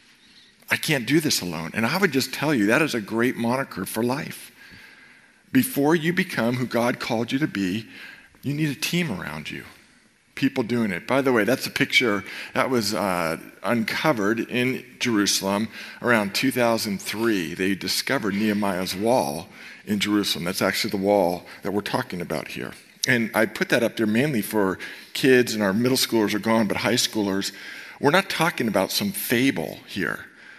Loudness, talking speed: -23 LUFS, 175 wpm